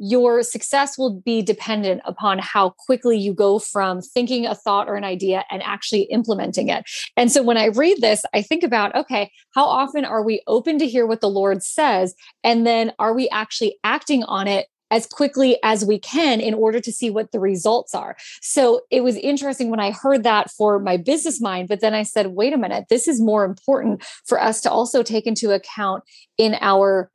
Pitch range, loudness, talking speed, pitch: 205-250 Hz, -19 LUFS, 210 wpm, 225 Hz